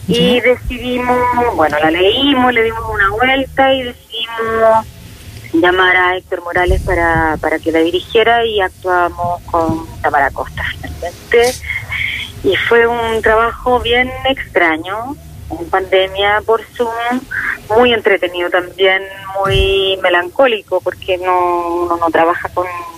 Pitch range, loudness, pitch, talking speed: 175-235 Hz, -13 LUFS, 195 Hz, 125 wpm